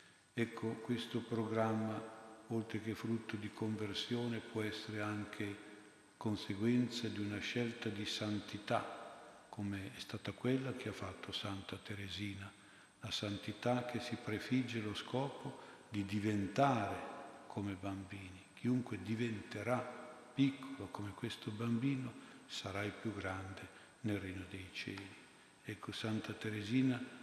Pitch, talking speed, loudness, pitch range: 110 Hz, 120 wpm, -41 LUFS, 100-115 Hz